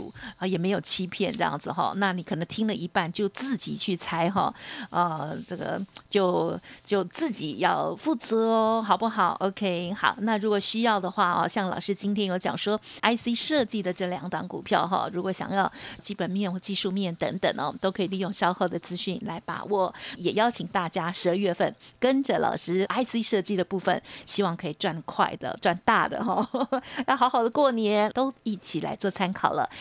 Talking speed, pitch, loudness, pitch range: 285 characters per minute, 200 Hz, -27 LUFS, 185-220 Hz